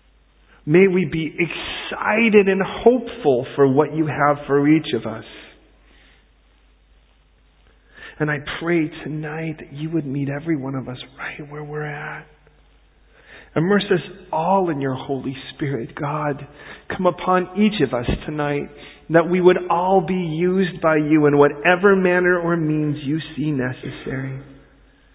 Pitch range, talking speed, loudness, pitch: 145-180 Hz, 145 wpm, -20 LUFS, 155 Hz